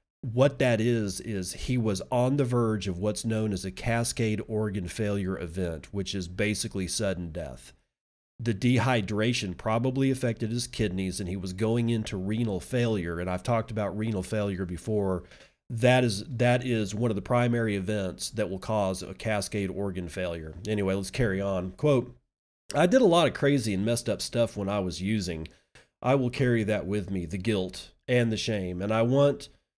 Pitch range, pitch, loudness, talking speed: 95-120 Hz, 105 Hz, -28 LUFS, 185 wpm